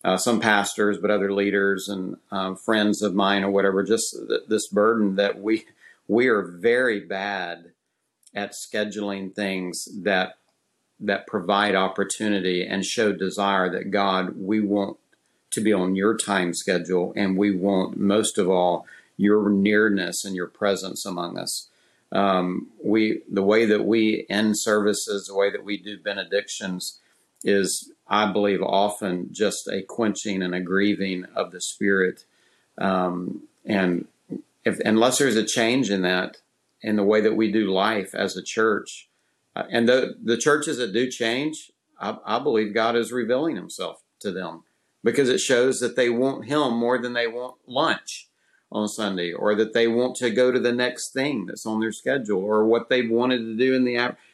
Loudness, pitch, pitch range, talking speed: -23 LUFS, 105 Hz, 100-115 Hz, 170 wpm